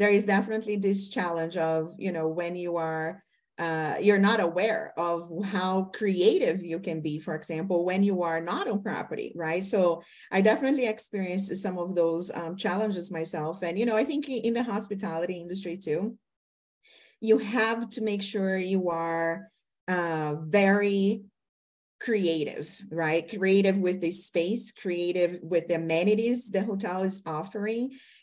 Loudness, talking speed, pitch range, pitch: -27 LUFS, 155 wpm, 170-210 Hz, 190 Hz